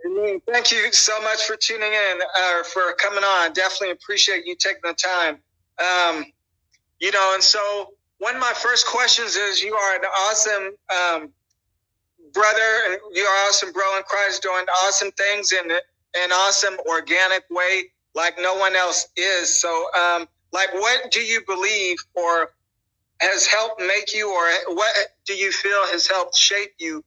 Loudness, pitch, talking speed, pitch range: -19 LUFS, 190 Hz, 170 wpm, 175-200 Hz